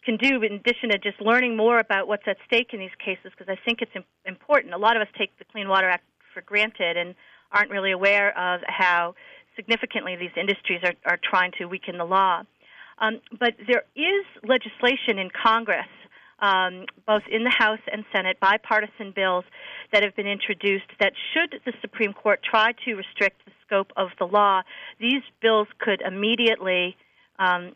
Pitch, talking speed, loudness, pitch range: 205 Hz, 185 wpm, -23 LUFS, 190-230 Hz